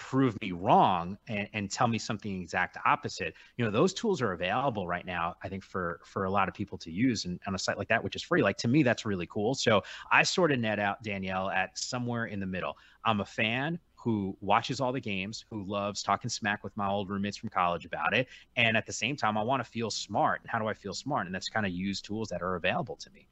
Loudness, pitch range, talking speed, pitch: -30 LUFS, 95-115 Hz, 265 wpm, 105 Hz